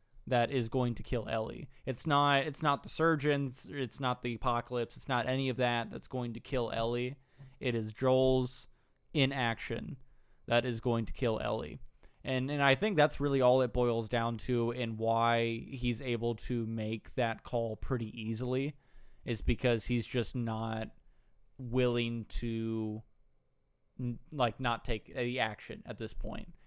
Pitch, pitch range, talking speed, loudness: 120 Hz, 115-130 Hz, 160 wpm, -33 LUFS